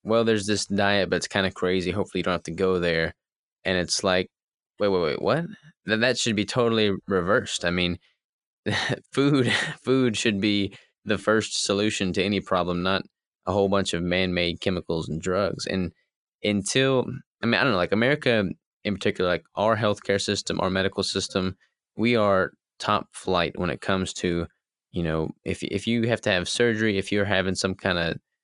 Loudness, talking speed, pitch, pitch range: -25 LUFS, 195 wpm, 100 Hz, 90-110 Hz